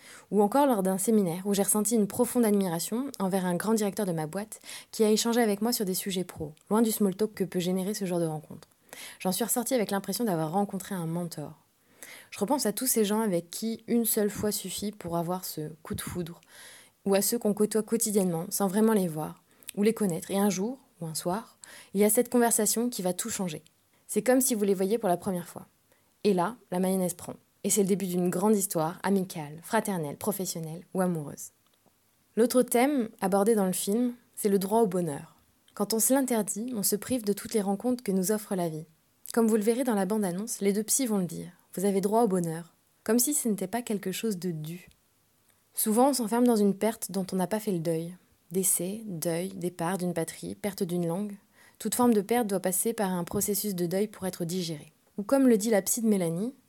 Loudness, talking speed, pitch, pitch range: -28 LUFS, 230 wpm, 200 Hz, 180-225 Hz